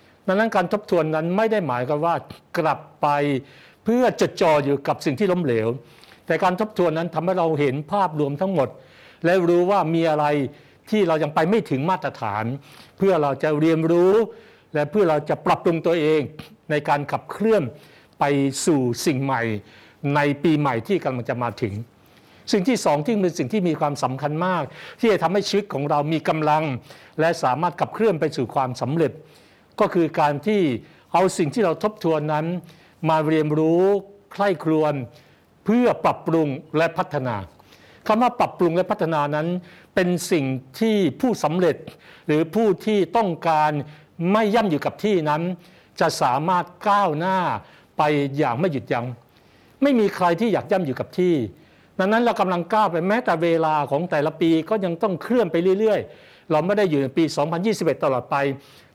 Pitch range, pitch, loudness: 145-190 Hz, 160 Hz, -22 LUFS